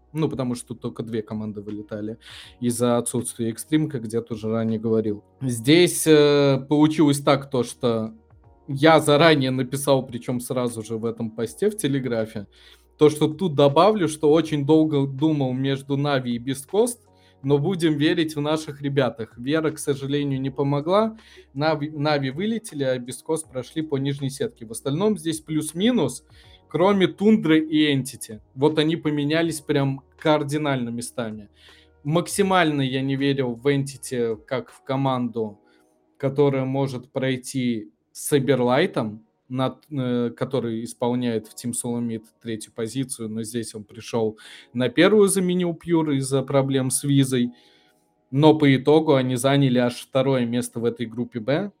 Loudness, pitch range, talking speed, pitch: -22 LUFS, 120-150 Hz, 140 wpm, 135 Hz